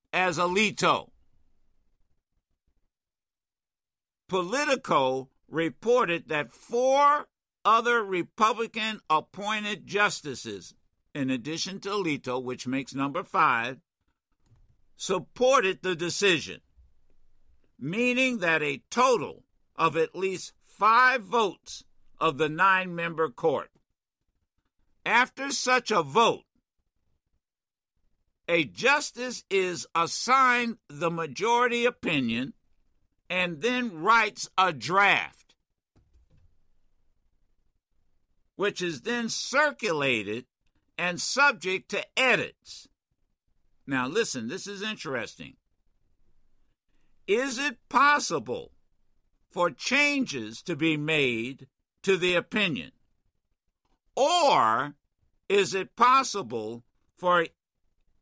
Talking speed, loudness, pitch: 80 wpm, -26 LUFS, 180 Hz